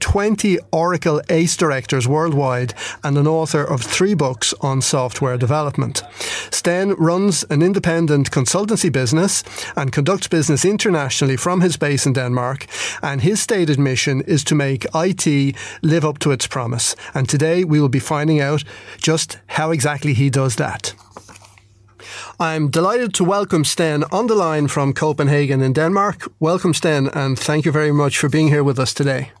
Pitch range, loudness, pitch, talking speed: 135-165 Hz, -17 LUFS, 150 Hz, 165 wpm